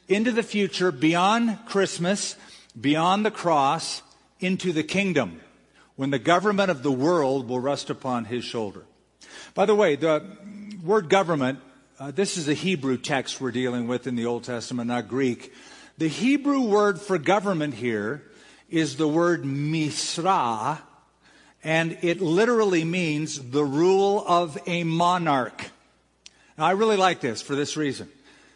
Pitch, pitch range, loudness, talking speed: 165 Hz, 135-195 Hz, -24 LUFS, 145 wpm